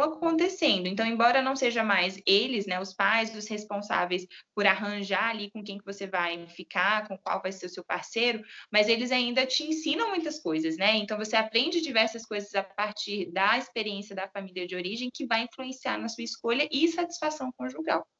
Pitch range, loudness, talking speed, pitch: 195-255 Hz, -28 LUFS, 190 wpm, 215 Hz